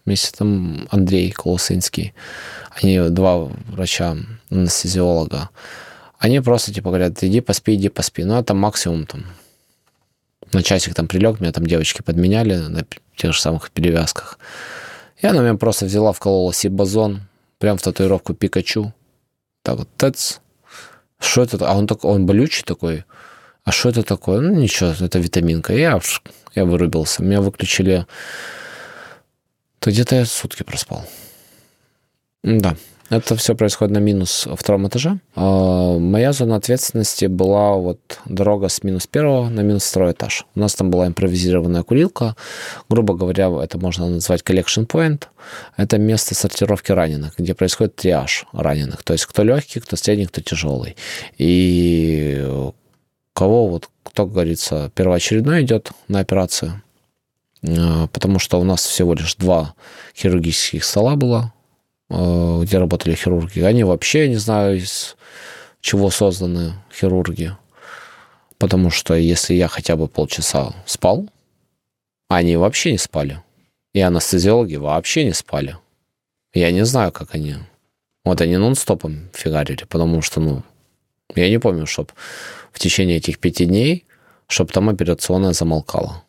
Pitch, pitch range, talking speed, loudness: 95 Hz, 85-105 Hz, 140 wpm, -17 LUFS